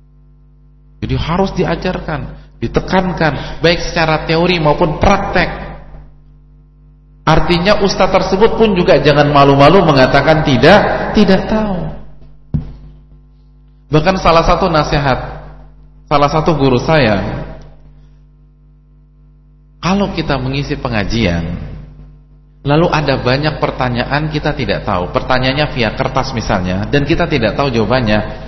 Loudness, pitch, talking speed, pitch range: -13 LUFS, 150 Hz, 100 wpm, 140-165 Hz